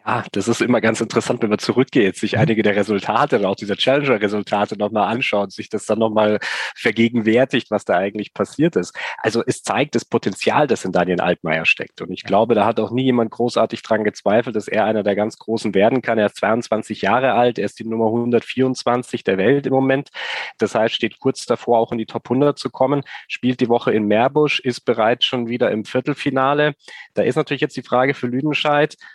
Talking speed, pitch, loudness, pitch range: 210 wpm, 115 Hz, -19 LUFS, 110-130 Hz